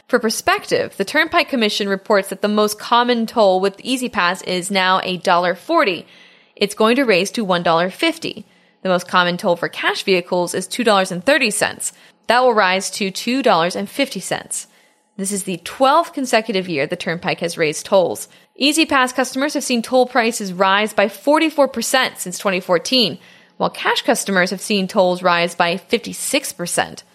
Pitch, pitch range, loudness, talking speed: 205 Hz, 185-250 Hz, -17 LUFS, 150 wpm